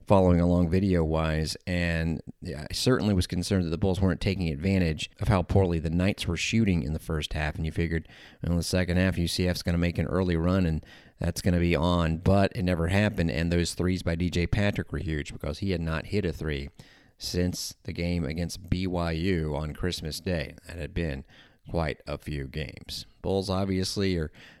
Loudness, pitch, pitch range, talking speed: -28 LUFS, 85 Hz, 80-95 Hz, 205 wpm